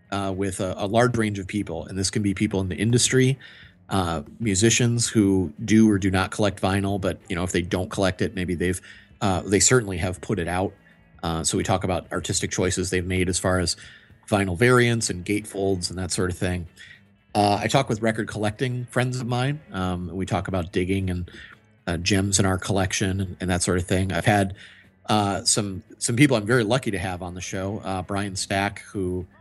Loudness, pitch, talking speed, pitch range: -23 LUFS, 100 Hz, 215 wpm, 90-110 Hz